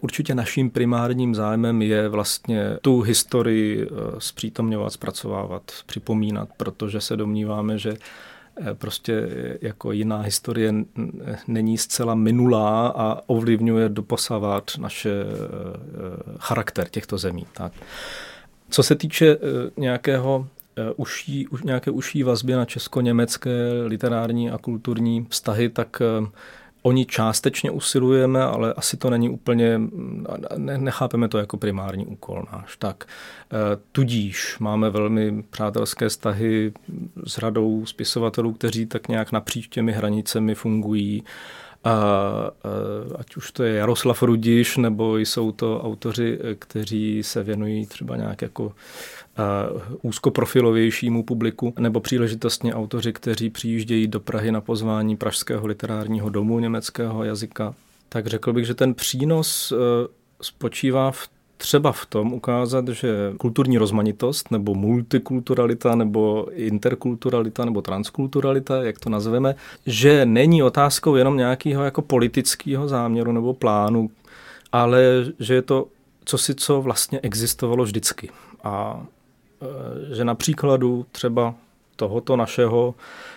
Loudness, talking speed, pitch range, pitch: -22 LUFS, 115 wpm, 110-125 Hz, 115 Hz